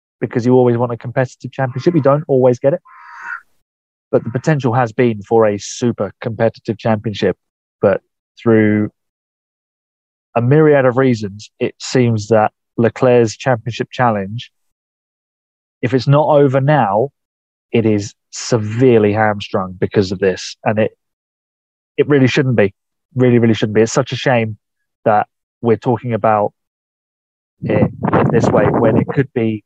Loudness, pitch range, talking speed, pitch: -15 LUFS, 110-130 Hz, 145 wpm, 120 Hz